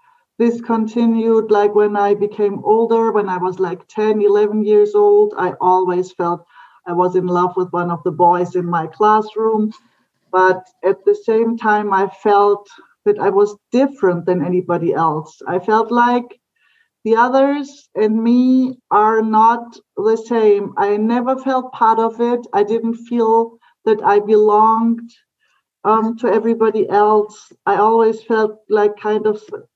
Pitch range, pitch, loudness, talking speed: 200-240 Hz, 220 Hz, -16 LUFS, 155 wpm